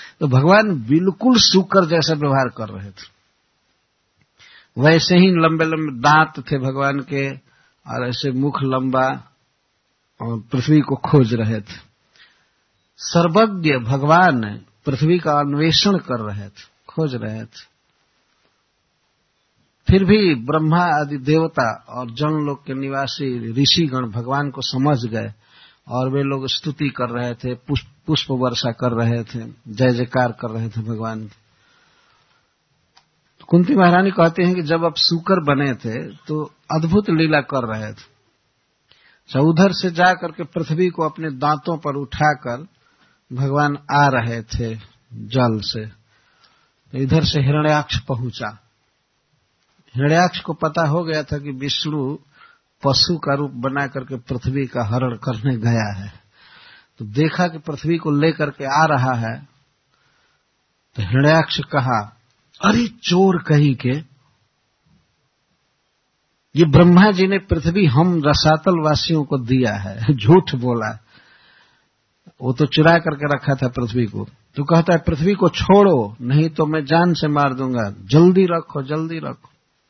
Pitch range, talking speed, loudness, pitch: 125-160 Hz, 135 wpm, -18 LUFS, 140 Hz